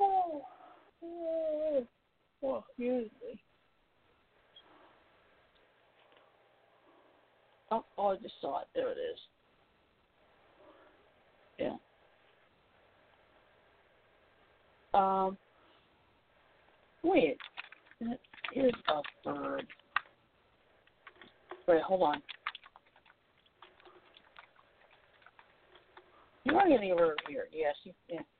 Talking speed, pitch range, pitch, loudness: 70 wpm, 230-360 Hz, 280 Hz, -34 LUFS